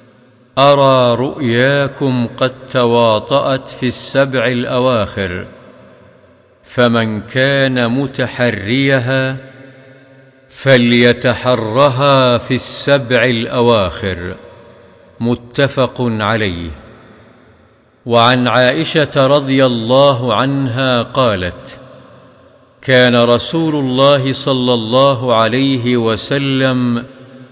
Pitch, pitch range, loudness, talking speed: 125 Hz, 120-135 Hz, -13 LUFS, 65 wpm